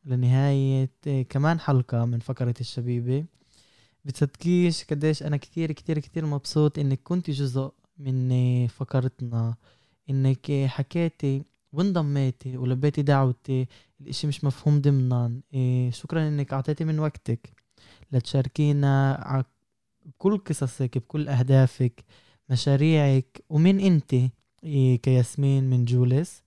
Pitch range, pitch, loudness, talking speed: 125-150 Hz, 135 Hz, -25 LUFS, 100 wpm